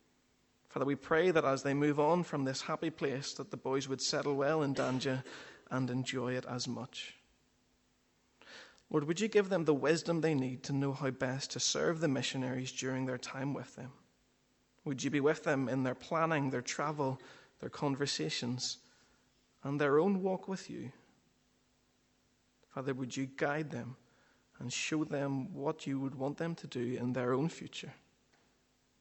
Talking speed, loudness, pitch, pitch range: 175 wpm, -35 LUFS, 135 Hz, 130-155 Hz